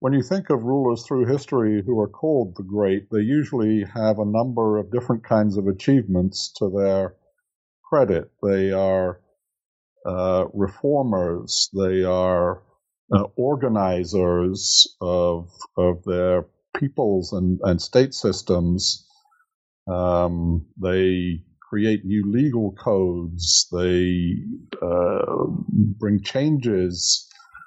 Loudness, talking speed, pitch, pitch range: -21 LUFS, 110 wpm, 100 Hz, 90-115 Hz